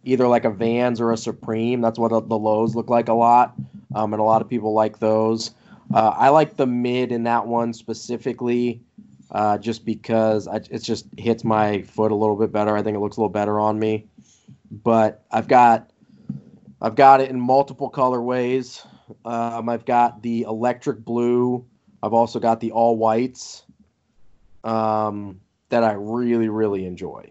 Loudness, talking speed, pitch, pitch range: -20 LUFS, 180 wpm, 115 Hz, 110-120 Hz